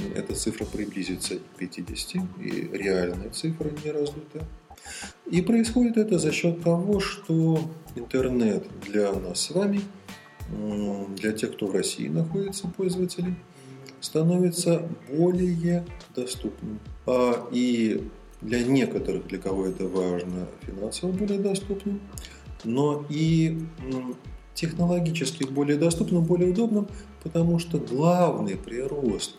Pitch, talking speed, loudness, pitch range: 155 Hz, 110 wpm, -26 LUFS, 115-180 Hz